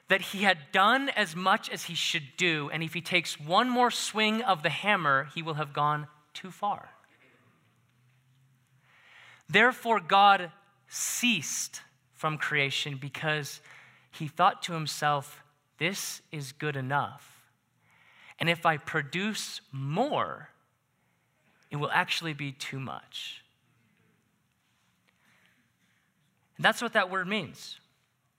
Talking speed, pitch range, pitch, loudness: 120 wpm, 145-195 Hz, 160 Hz, -28 LUFS